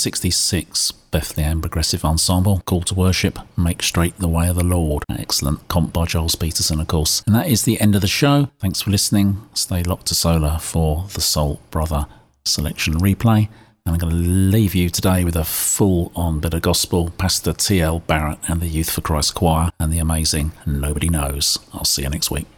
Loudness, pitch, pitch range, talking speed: -19 LUFS, 85 Hz, 80-95 Hz, 200 wpm